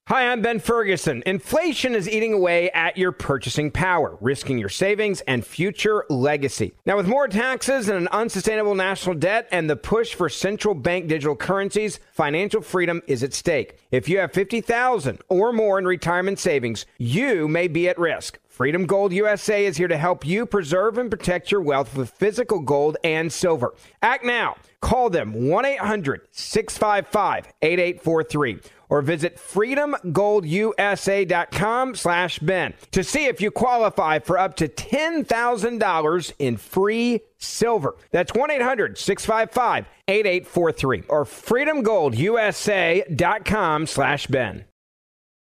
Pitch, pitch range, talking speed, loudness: 190 Hz, 160-215 Hz, 130 wpm, -22 LUFS